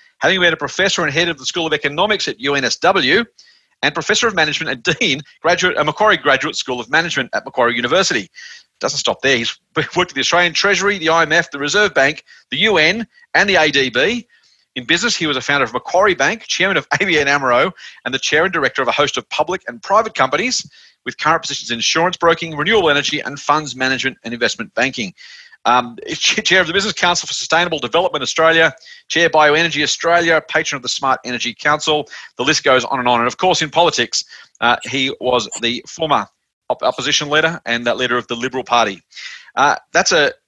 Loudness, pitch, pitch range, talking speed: -15 LUFS, 160 Hz, 140-180 Hz, 200 wpm